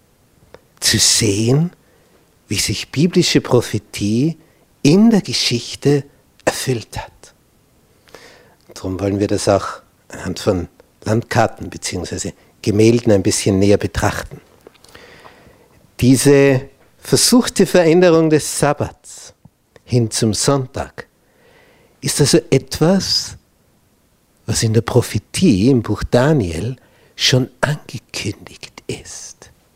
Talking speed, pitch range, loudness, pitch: 95 wpm, 105-145 Hz, -16 LUFS, 120 Hz